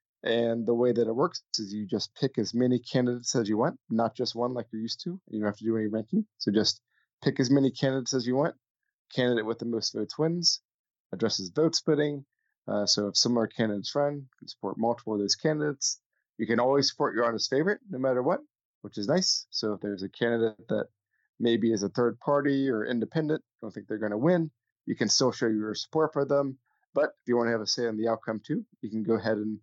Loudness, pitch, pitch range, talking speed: -28 LUFS, 120 Hz, 110-140 Hz, 240 wpm